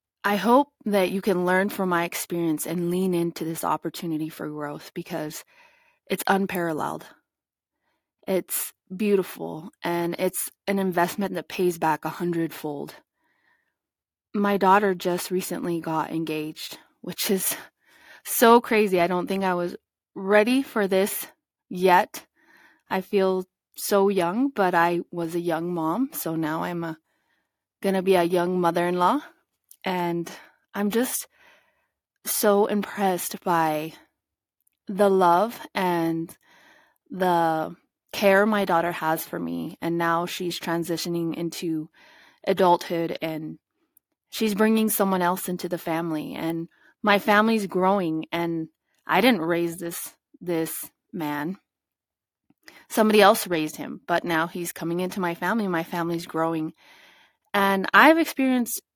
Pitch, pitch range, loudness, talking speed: 180 Hz, 165-205 Hz, -24 LUFS, 130 wpm